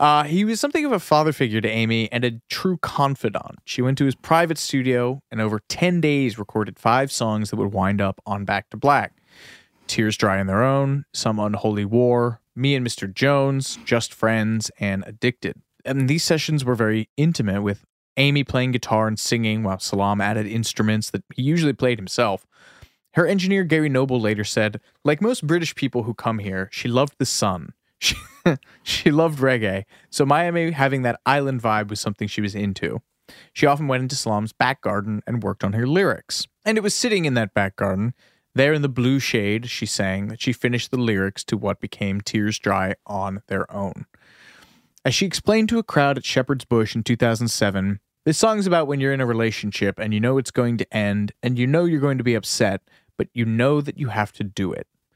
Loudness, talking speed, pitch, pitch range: -22 LUFS, 205 wpm, 120 Hz, 105-140 Hz